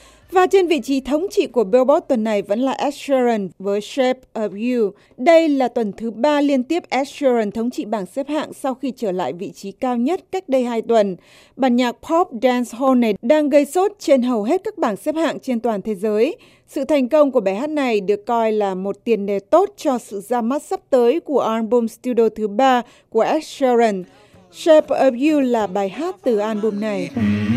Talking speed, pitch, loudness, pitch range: 220 wpm, 250 Hz, -19 LUFS, 220-295 Hz